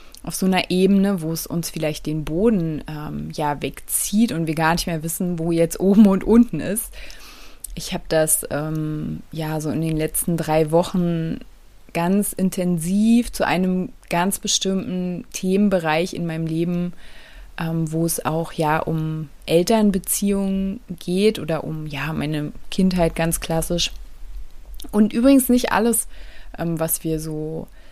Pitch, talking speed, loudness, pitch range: 170 Hz, 150 wpm, -21 LUFS, 160-190 Hz